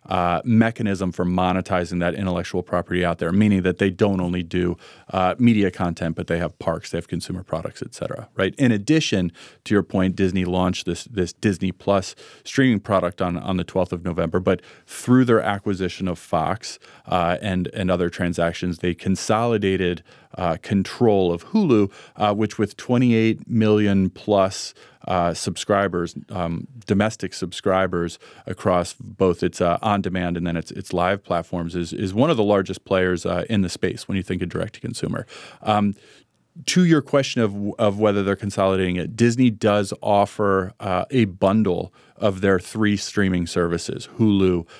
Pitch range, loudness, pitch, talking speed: 90-105 Hz, -22 LUFS, 95 Hz, 170 wpm